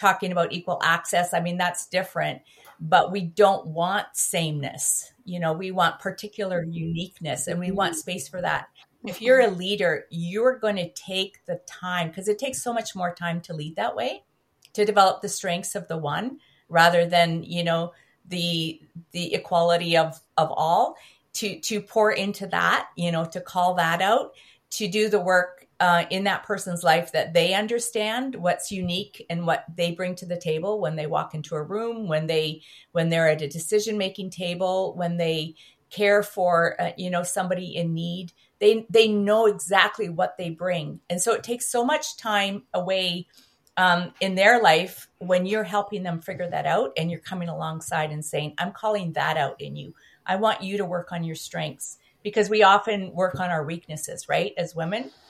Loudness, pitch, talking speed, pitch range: -24 LUFS, 180 Hz, 190 wpm, 170-200 Hz